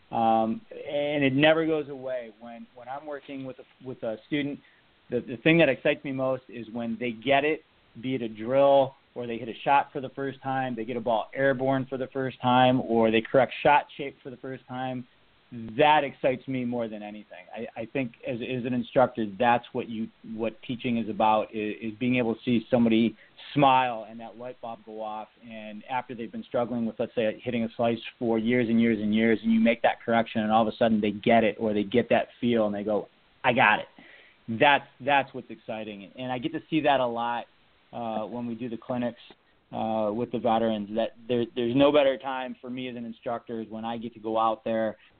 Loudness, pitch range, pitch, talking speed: -26 LUFS, 115-130 Hz, 120 Hz, 230 wpm